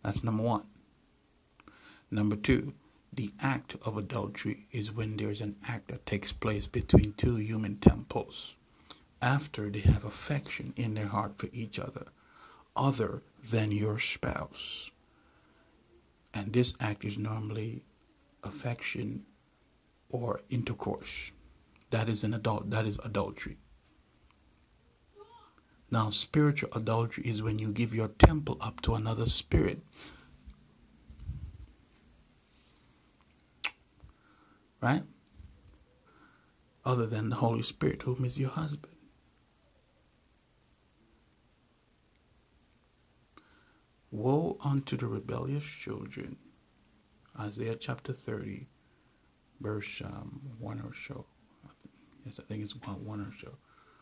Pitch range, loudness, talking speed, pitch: 100-115 Hz, -33 LUFS, 105 wpm, 105 Hz